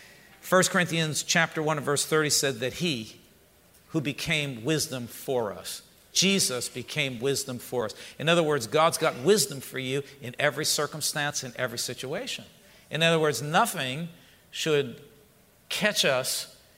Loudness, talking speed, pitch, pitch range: -26 LUFS, 145 wpm, 145 Hz, 130-160 Hz